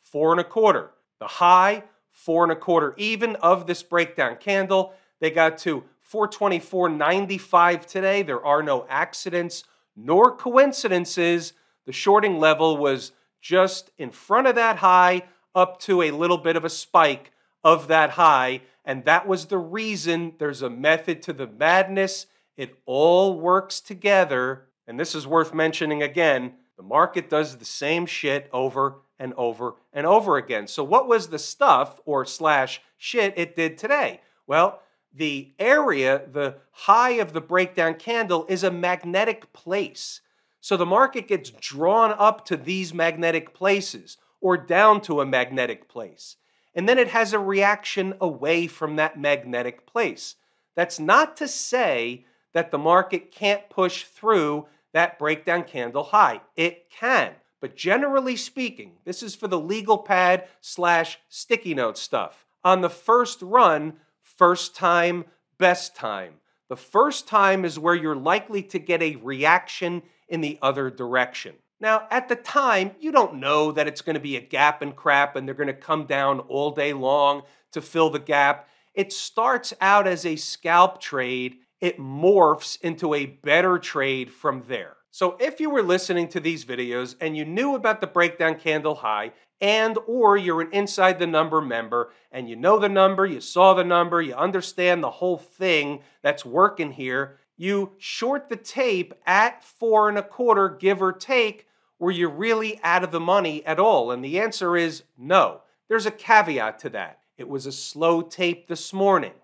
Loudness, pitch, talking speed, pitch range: -22 LUFS, 175 Hz, 170 wpm, 150-195 Hz